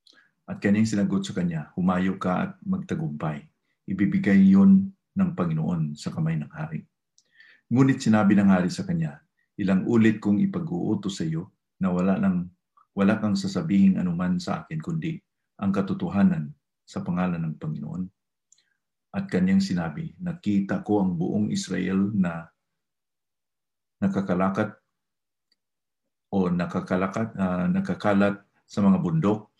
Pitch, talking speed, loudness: 130 Hz, 125 wpm, -25 LUFS